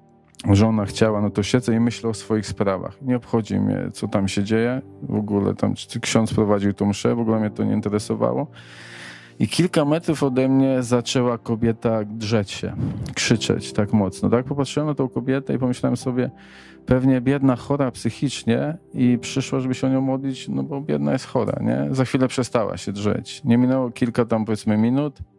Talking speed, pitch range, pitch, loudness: 185 wpm, 105-130 Hz, 115 Hz, -22 LUFS